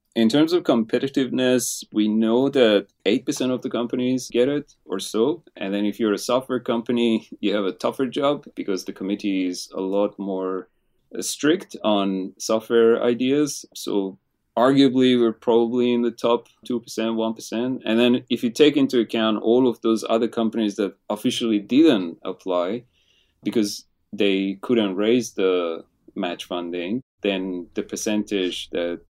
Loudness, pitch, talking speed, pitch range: -22 LUFS, 115 Hz, 150 wpm, 100-125 Hz